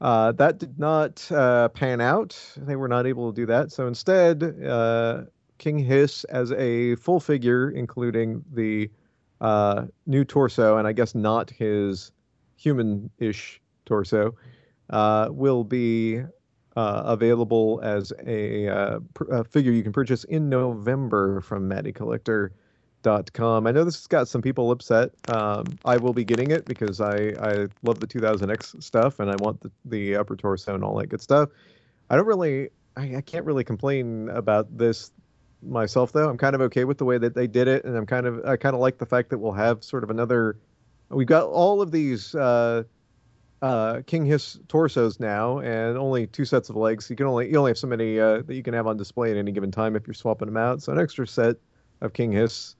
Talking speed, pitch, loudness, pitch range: 200 wpm, 120 Hz, -24 LUFS, 110-130 Hz